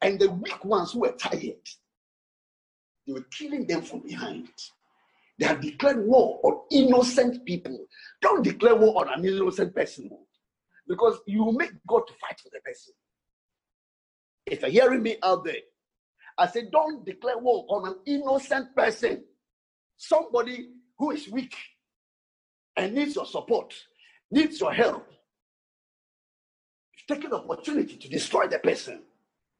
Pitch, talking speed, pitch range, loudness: 265 Hz, 140 wpm, 220-340 Hz, -25 LUFS